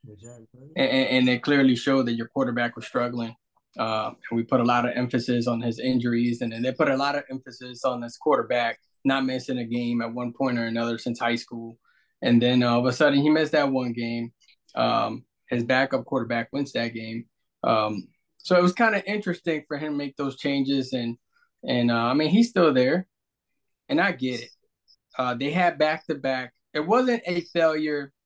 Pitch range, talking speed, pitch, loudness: 120-150 Hz, 210 wpm, 130 Hz, -24 LUFS